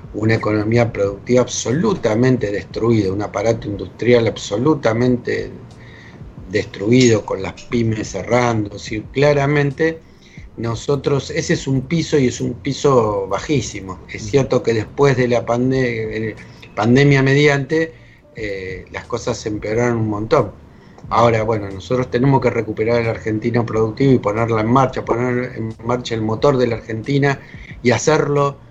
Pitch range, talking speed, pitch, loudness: 110-135 Hz, 135 wpm, 120 Hz, -18 LUFS